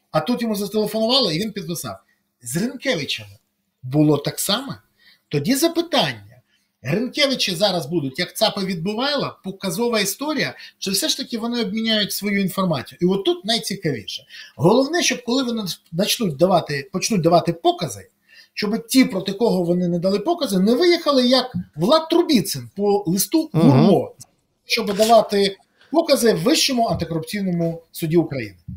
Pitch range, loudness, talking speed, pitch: 170-240 Hz, -20 LUFS, 140 wpm, 205 Hz